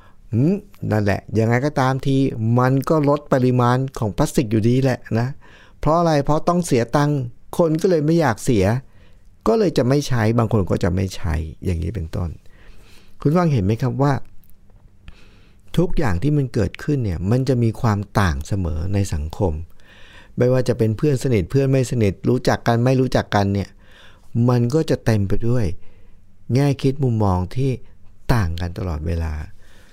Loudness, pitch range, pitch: -20 LUFS, 95-135 Hz, 110 Hz